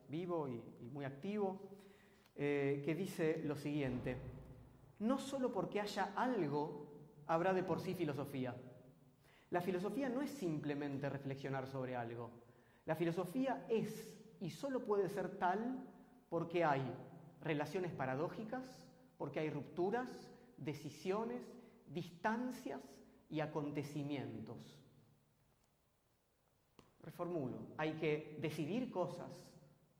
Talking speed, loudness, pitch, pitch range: 100 wpm, -42 LUFS, 165 Hz, 140-195 Hz